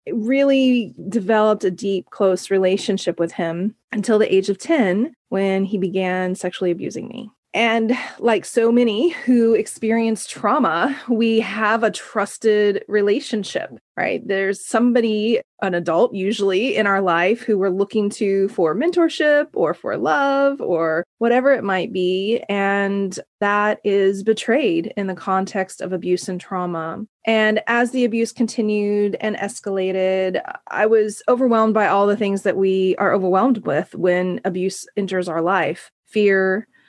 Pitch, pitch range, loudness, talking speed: 205 Hz, 190-230 Hz, -19 LUFS, 150 wpm